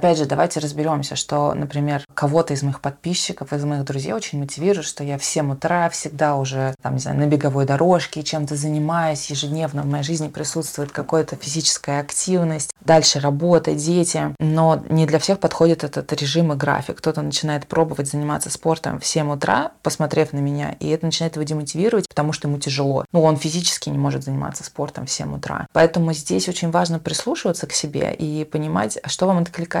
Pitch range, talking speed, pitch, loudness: 145-165 Hz, 185 wpm, 155 Hz, -20 LUFS